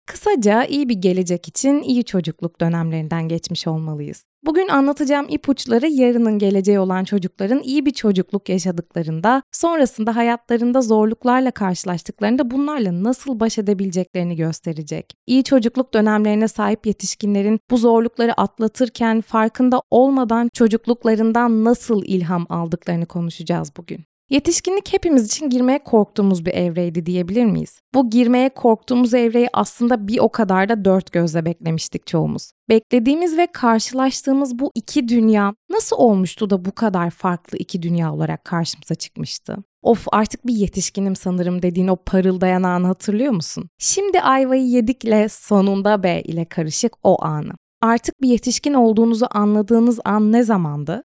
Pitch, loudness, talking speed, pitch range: 220 Hz, -18 LUFS, 135 wpm, 185-250 Hz